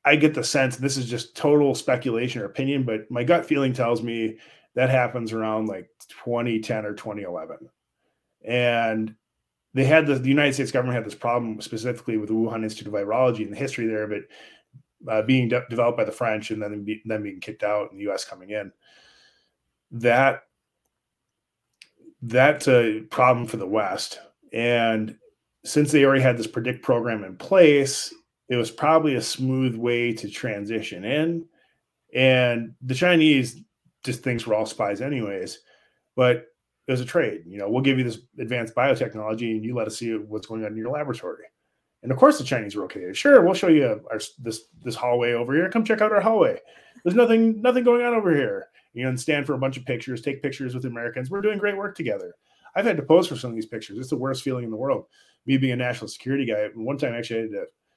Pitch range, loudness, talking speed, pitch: 110-145 Hz, -23 LUFS, 210 wpm, 125 Hz